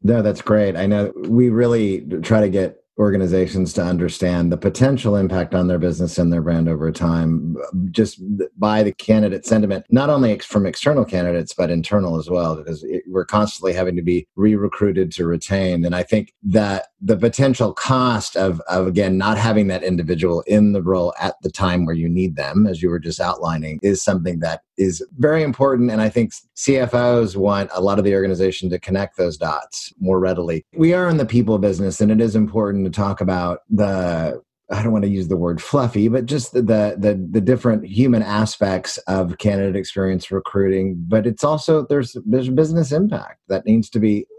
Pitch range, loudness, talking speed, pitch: 90-110 Hz, -18 LUFS, 200 wpm, 100 Hz